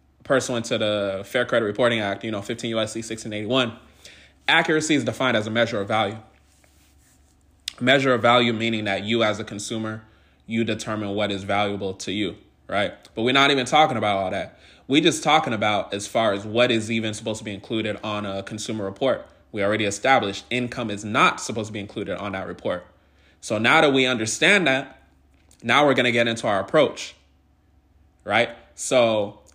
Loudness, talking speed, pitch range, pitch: -22 LUFS, 185 wpm, 100-120 Hz, 110 Hz